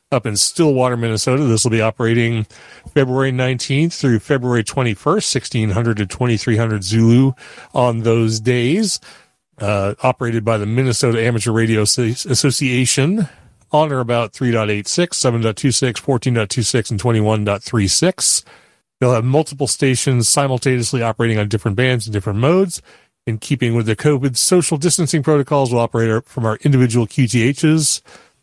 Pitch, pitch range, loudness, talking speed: 120 Hz, 115-135 Hz, -16 LUFS, 130 wpm